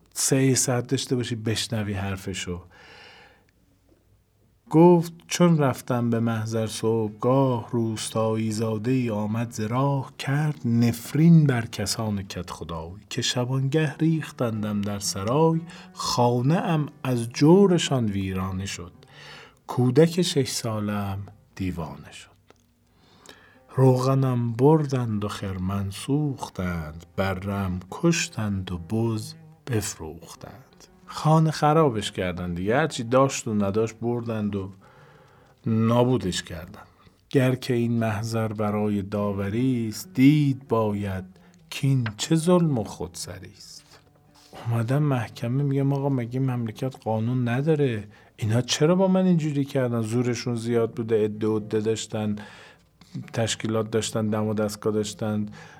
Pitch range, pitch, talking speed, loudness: 105-135 Hz, 115 Hz, 110 wpm, -24 LUFS